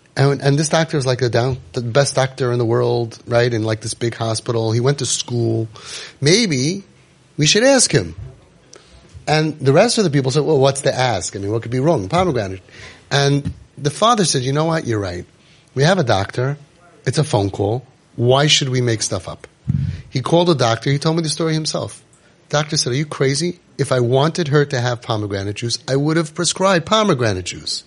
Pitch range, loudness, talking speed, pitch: 115-155 Hz, -17 LUFS, 210 wpm, 135 Hz